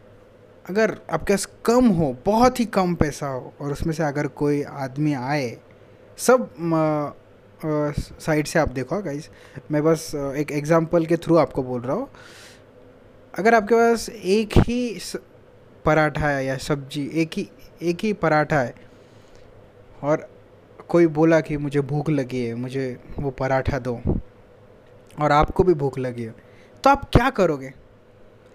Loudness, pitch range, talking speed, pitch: -22 LUFS, 125-170 Hz, 145 wpm, 150 Hz